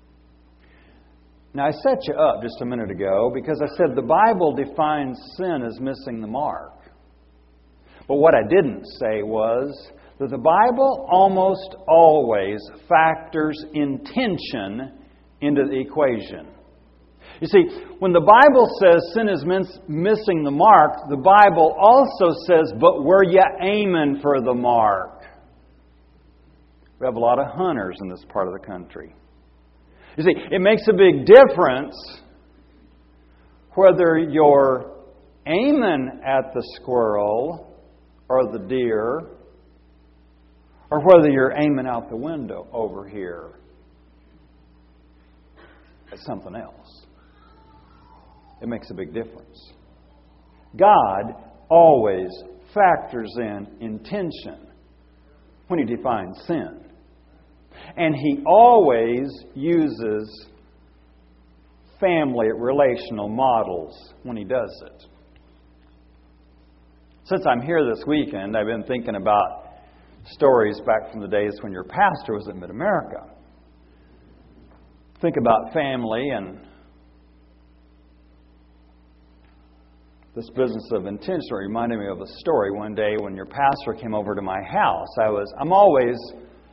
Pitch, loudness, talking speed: 100 Hz, -19 LUFS, 120 wpm